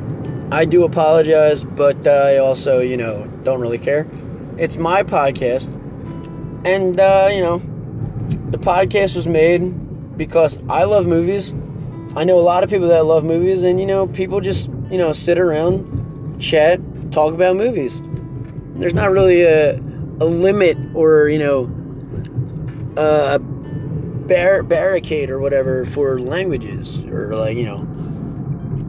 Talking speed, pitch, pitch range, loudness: 145 wpm, 150 Hz, 140-175 Hz, -16 LUFS